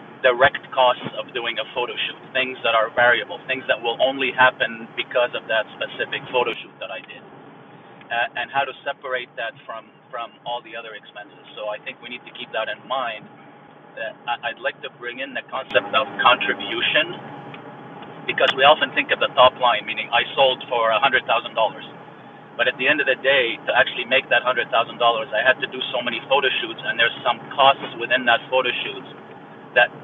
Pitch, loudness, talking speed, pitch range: 125 Hz, -20 LUFS, 200 wpm, 115-130 Hz